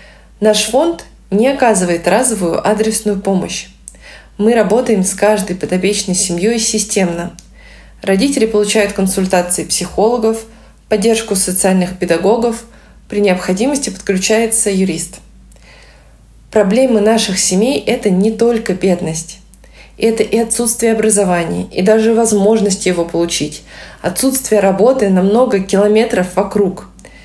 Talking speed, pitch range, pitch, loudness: 105 wpm, 185-225 Hz, 205 Hz, -13 LUFS